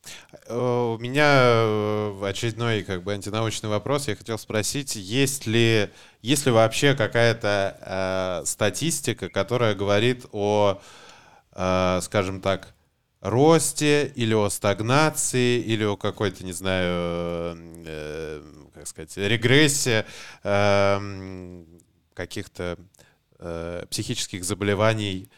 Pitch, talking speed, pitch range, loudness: 105 Hz, 95 wpm, 95-120 Hz, -23 LUFS